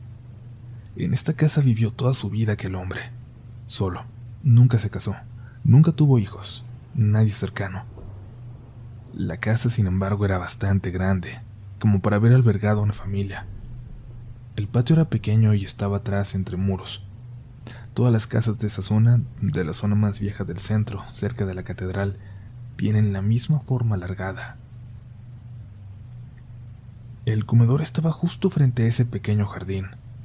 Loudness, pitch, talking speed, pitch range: -23 LUFS, 115 Hz, 145 wpm, 100-120 Hz